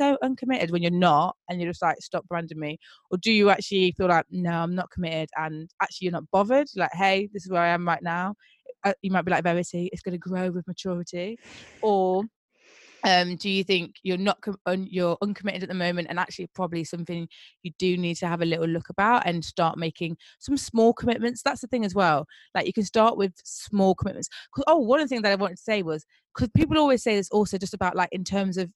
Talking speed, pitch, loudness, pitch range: 240 wpm, 185 Hz, -25 LUFS, 175-205 Hz